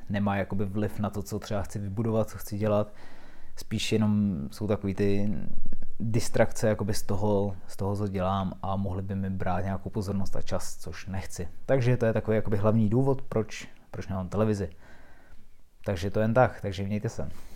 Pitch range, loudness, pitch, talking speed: 95-110 Hz, -29 LUFS, 100 Hz, 180 wpm